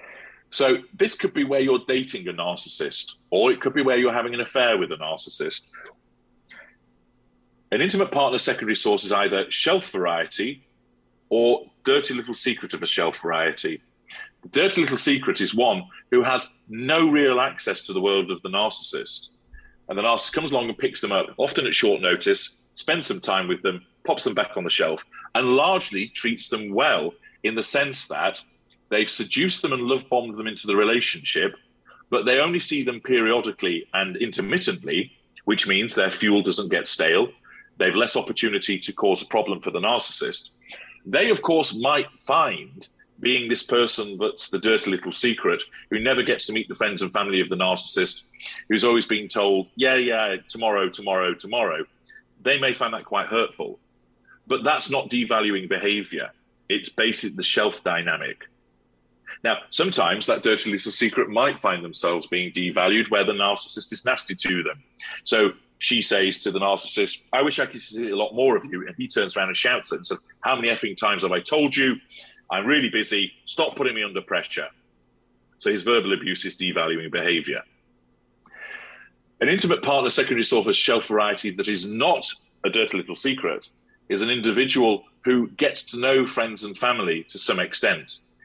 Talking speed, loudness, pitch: 180 wpm, -22 LUFS, 125 Hz